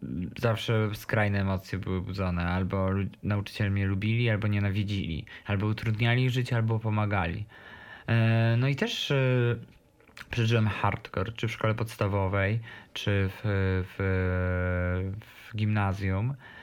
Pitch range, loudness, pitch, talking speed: 95-115 Hz, -29 LUFS, 105 Hz, 110 wpm